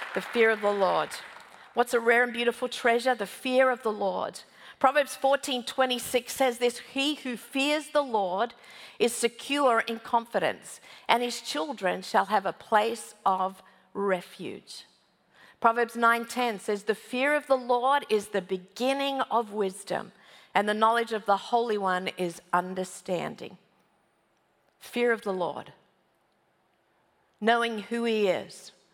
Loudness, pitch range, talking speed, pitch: -27 LUFS, 200-250 Hz, 140 wpm, 235 Hz